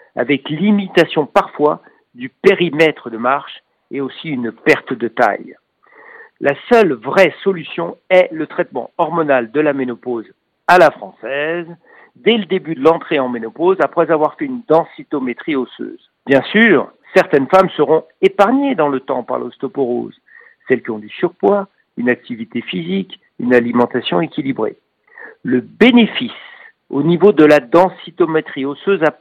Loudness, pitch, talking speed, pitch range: -15 LUFS, 165 Hz, 145 wpm, 140-195 Hz